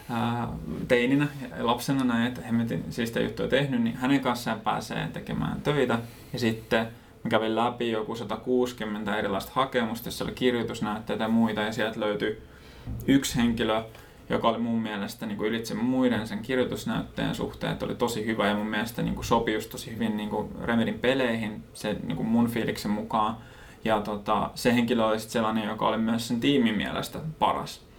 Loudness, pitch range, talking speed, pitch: -28 LUFS, 110-125 Hz, 170 wpm, 115 Hz